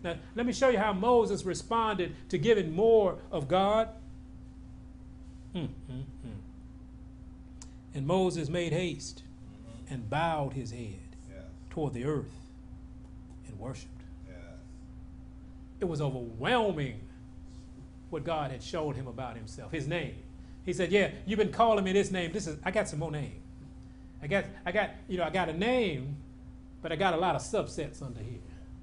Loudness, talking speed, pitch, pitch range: -31 LUFS, 150 wpm, 155 Hz, 120-185 Hz